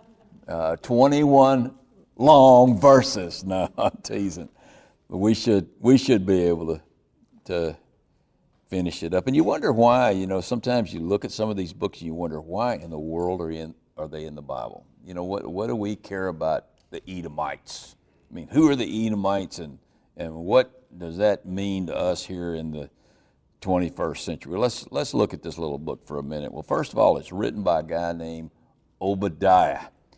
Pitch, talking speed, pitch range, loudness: 95 Hz, 195 wpm, 85-110 Hz, -23 LUFS